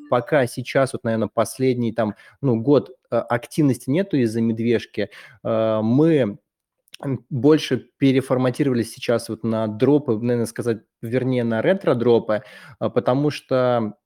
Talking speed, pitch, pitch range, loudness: 110 wpm, 120 Hz, 115-135 Hz, -21 LUFS